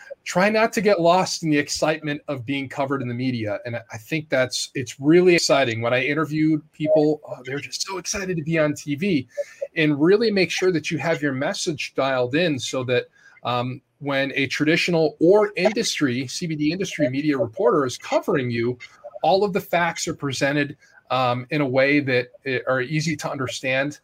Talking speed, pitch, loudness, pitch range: 185 wpm, 150 Hz, -22 LUFS, 130-170 Hz